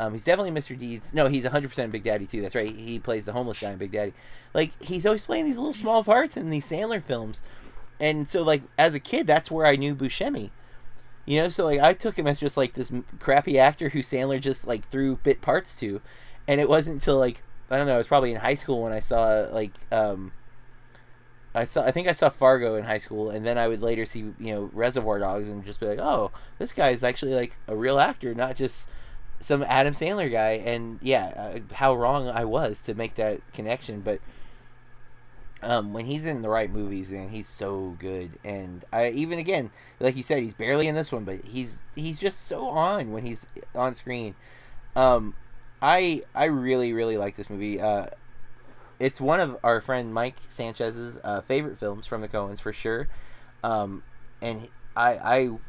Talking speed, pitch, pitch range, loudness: 210 wpm, 125 Hz, 110-135 Hz, -26 LUFS